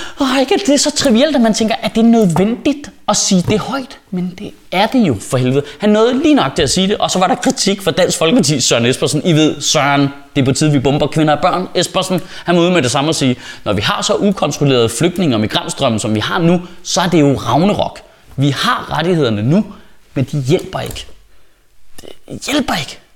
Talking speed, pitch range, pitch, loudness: 245 wpm, 145-210 Hz, 180 Hz, -14 LUFS